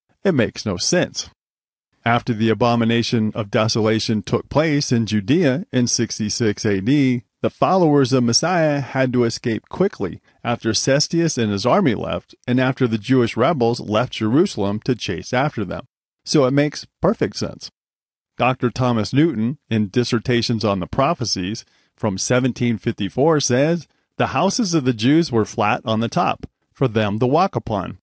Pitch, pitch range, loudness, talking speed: 120 Hz, 110-130 Hz, -19 LUFS, 155 wpm